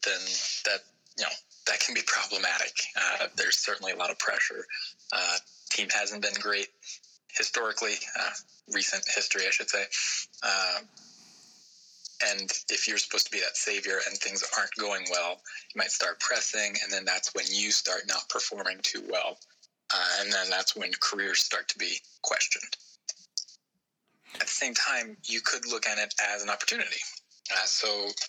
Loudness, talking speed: -28 LUFS, 170 wpm